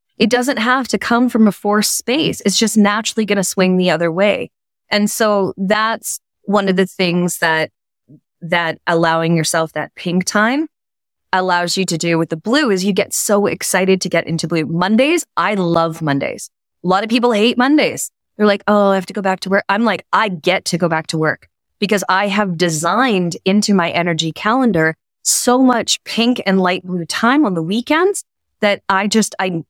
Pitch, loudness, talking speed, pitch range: 195 Hz, -16 LUFS, 200 wpm, 170-220 Hz